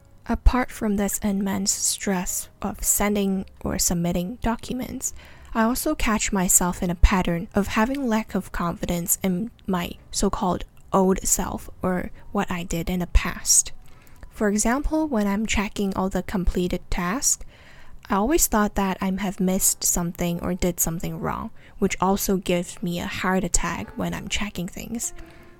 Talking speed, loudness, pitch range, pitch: 155 wpm, -24 LUFS, 180-215 Hz, 195 Hz